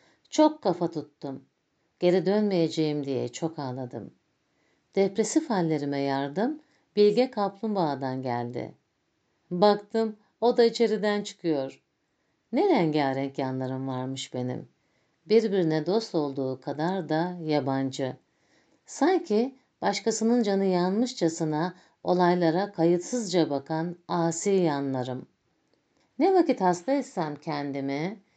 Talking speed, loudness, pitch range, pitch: 95 wpm, -27 LUFS, 140-210 Hz, 170 Hz